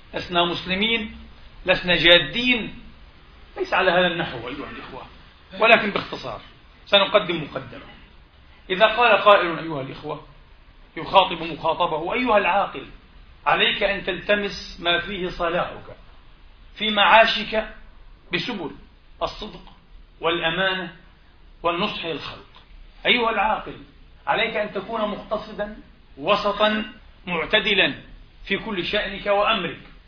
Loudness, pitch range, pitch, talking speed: -21 LUFS, 170-210 Hz, 190 Hz, 95 wpm